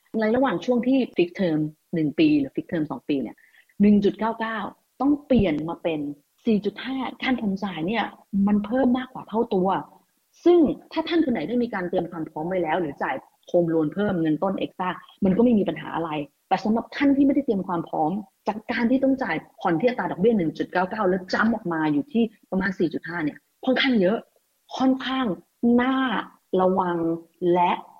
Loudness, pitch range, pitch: -24 LUFS, 175-250 Hz, 205 Hz